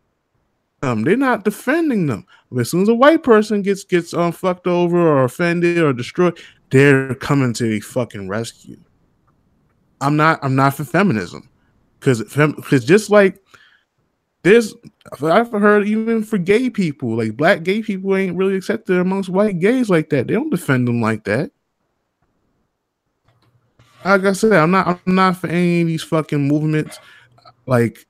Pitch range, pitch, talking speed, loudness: 135-200 Hz, 170 Hz, 160 wpm, -17 LUFS